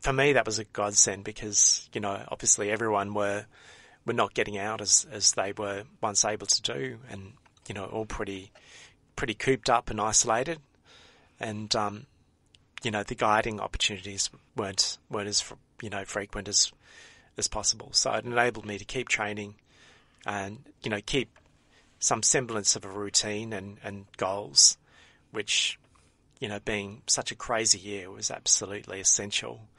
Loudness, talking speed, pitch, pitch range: -27 LUFS, 160 wpm, 105 Hz, 100-115 Hz